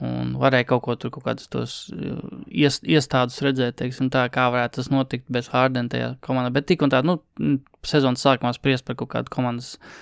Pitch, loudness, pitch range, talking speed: 130 Hz, -23 LUFS, 125-135 Hz, 160 wpm